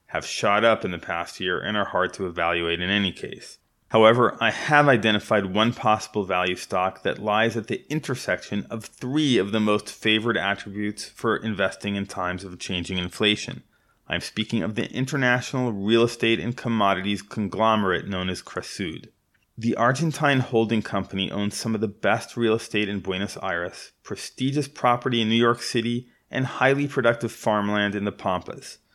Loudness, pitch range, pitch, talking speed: -24 LUFS, 100-120 Hz, 110 Hz, 170 wpm